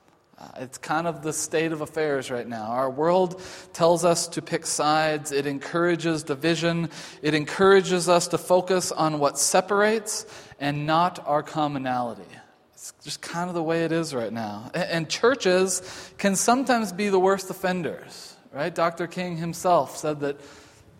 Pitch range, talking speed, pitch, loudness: 150-180 Hz, 155 wpm, 165 Hz, -24 LUFS